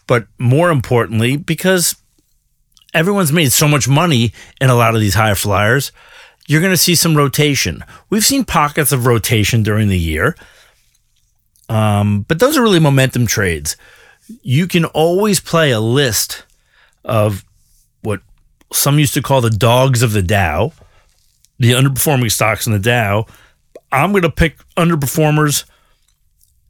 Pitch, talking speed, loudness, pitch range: 125 Hz, 145 wpm, -14 LUFS, 105-150 Hz